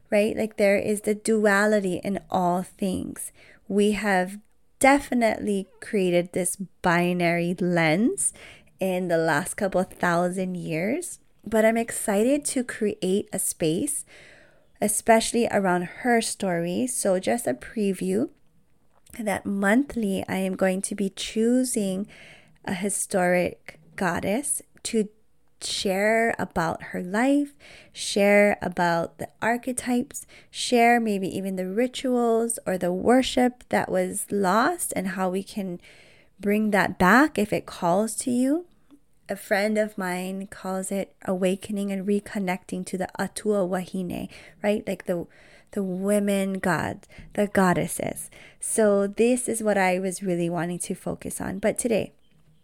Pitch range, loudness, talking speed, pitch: 185-225 Hz, -25 LUFS, 130 wpm, 200 Hz